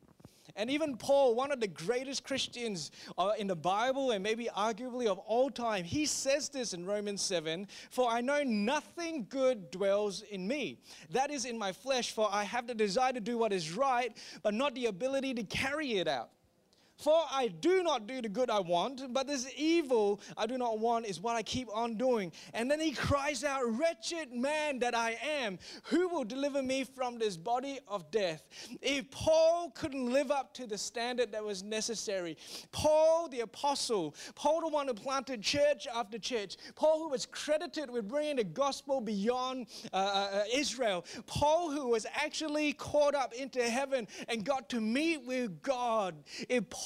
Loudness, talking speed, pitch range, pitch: -33 LUFS, 185 wpm, 220-285 Hz, 255 Hz